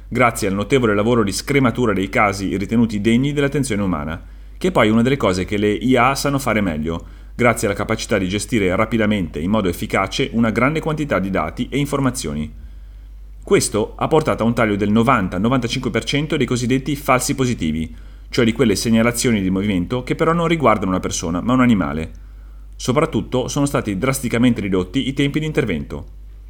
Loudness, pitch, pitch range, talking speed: -18 LUFS, 115 Hz, 95-130 Hz, 175 wpm